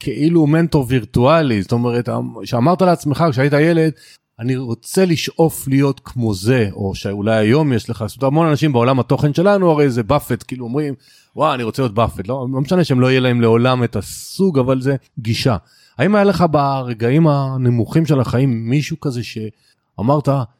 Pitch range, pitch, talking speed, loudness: 120-150 Hz, 130 Hz, 170 wpm, -16 LUFS